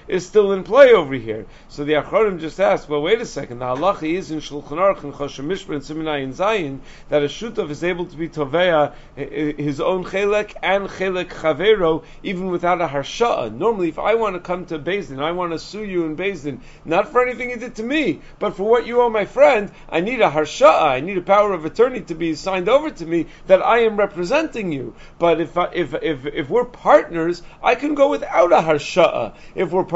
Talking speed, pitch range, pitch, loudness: 215 wpm, 155-210 Hz, 175 Hz, -19 LUFS